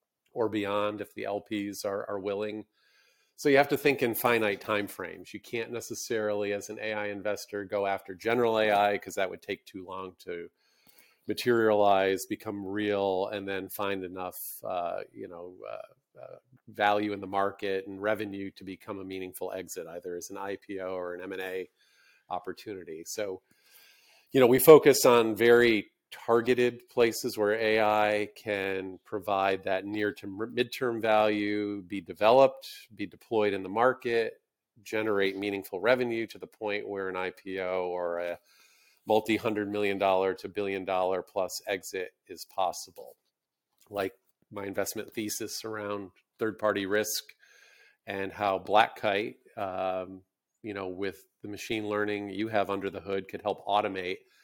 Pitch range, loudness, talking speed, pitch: 95-115 Hz, -29 LUFS, 155 wpm, 105 Hz